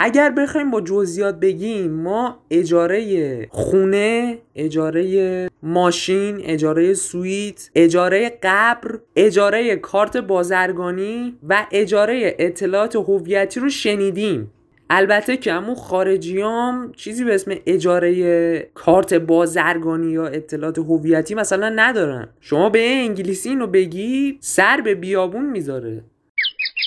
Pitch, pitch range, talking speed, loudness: 190 Hz, 175-220 Hz, 105 wpm, -18 LUFS